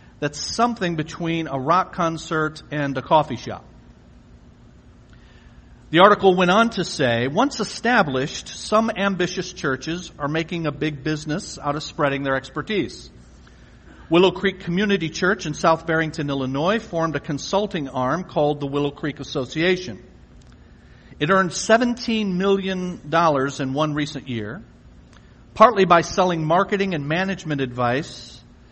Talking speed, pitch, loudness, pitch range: 130 wpm, 160 Hz, -21 LUFS, 145-185 Hz